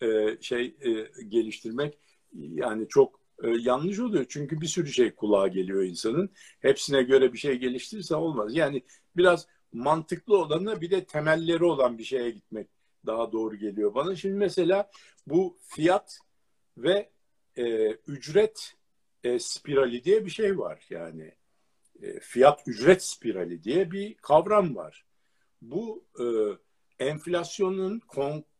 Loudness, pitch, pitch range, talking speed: -27 LUFS, 170 Hz, 125-205 Hz, 120 wpm